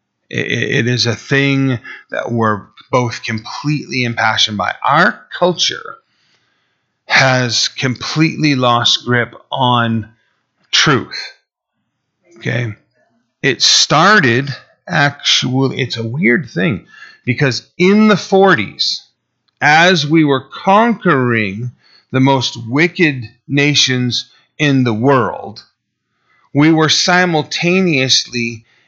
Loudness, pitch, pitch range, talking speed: -13 LUFS, 130 Hz, 120-155 Hz, 90 wpm